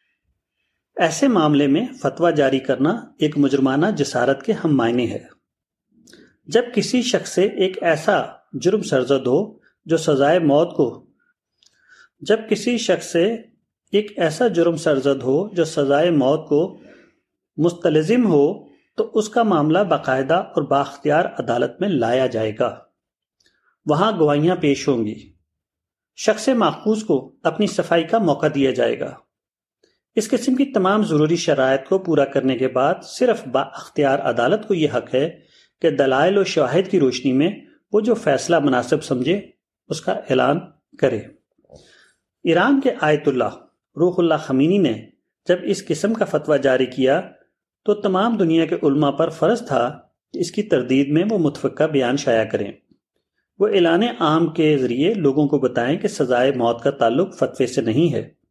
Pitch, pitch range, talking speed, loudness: 160 Hz, 140-205 Hz, 155 wpm, -19 LUFS